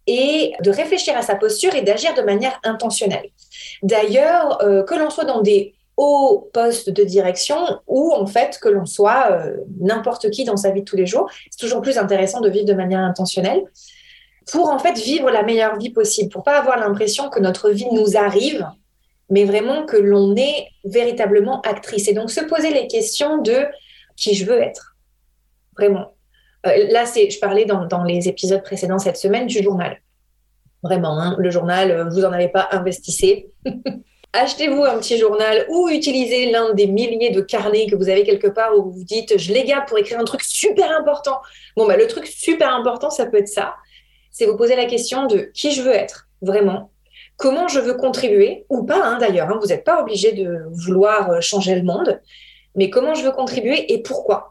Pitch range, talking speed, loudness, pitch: 200-290 Hz, 200 wpm, -17 LUFS, 225 Hz